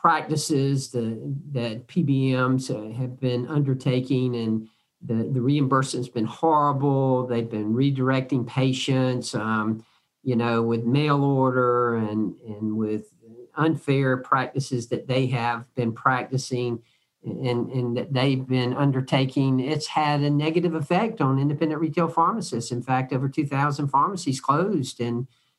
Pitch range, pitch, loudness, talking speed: 120-140 Hz, 130 Hz, -24 LUFS, 130 wpm